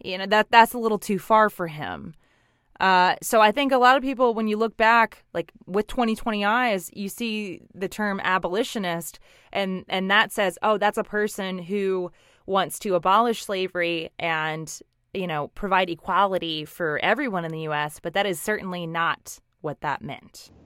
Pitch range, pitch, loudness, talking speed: 175-215 Hz, 195 Hz, -23 LUFS, 180 wpm